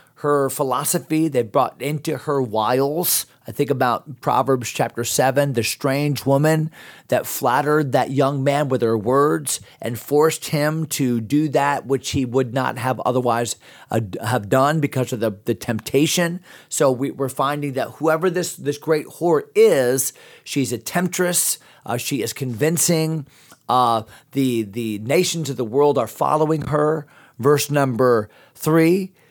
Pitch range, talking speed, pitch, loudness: 125-155 Hz, 155 wpm, 140 Hz, -20 LUFS